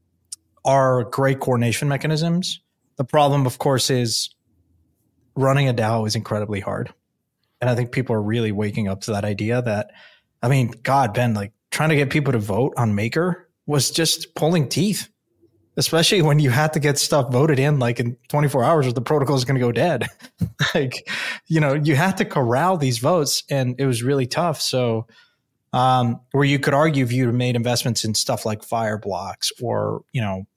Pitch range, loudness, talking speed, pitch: 115-145 Hz, -20 LUFS, 190 wpm, 130 Hz